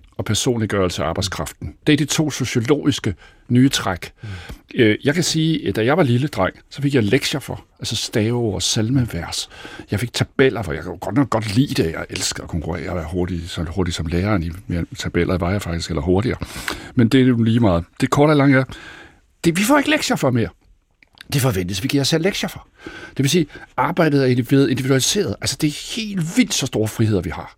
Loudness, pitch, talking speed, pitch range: -19 LUFS, 120 Hz, 215 wpm, 95-140 Hz